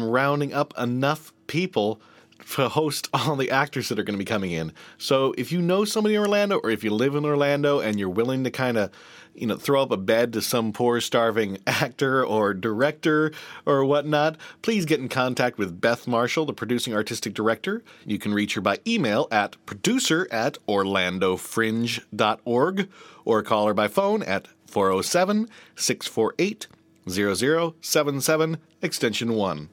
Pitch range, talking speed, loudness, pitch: 110-155 Hz, 160 wpm, -24 LUFS, 125 Hz